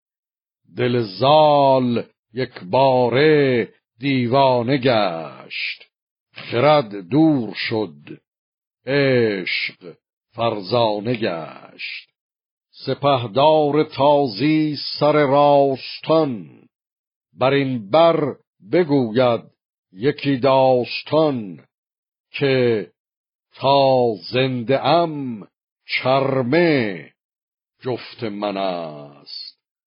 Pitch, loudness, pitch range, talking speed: 130 Hz, -18 LUFS, 120-145 Hz, 60 wpm